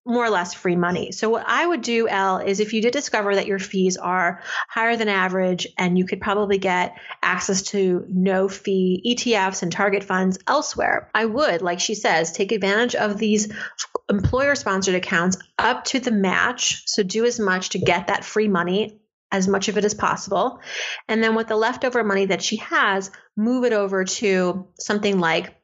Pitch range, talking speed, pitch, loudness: 185-225 Hz, 195 wpm, 200 Hz, -21 LUFS